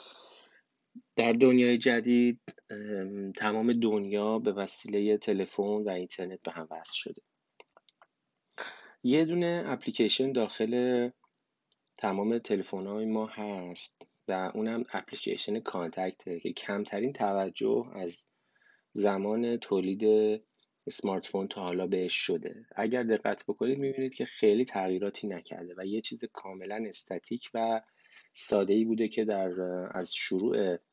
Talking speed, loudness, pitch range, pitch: 115 wpm, -31 LUFS, 95-120 Hz, 105 Hz